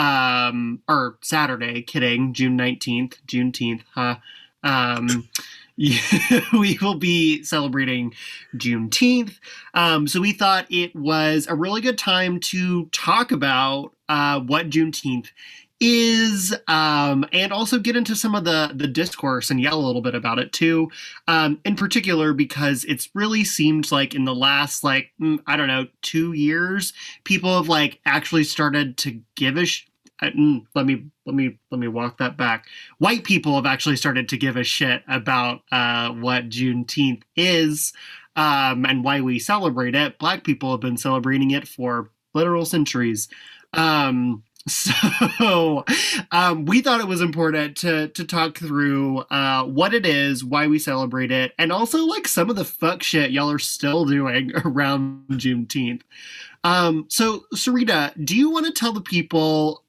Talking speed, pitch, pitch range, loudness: 155 wpm, 150 Hz, 130-175 Hz, -20 LUFS